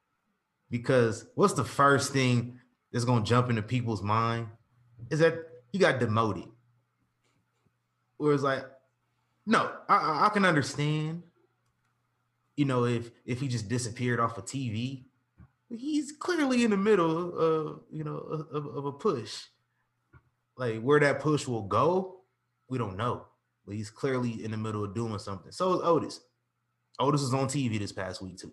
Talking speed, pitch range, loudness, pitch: 160 wpm, 115-145 Hz, -29 LUFS, 125 Hz